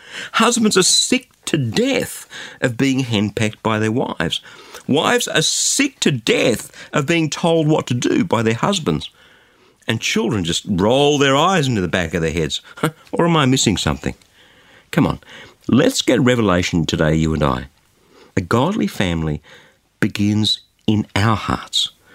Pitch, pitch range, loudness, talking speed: 110 Hz, 90-150 Hz, -17 LUFS, 155 wpm